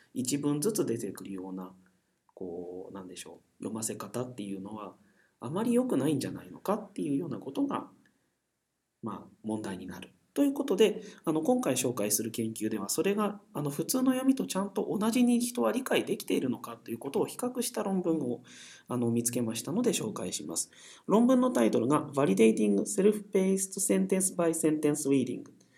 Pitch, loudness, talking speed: 155 Hz, -30 LUFS, 425 characters per minute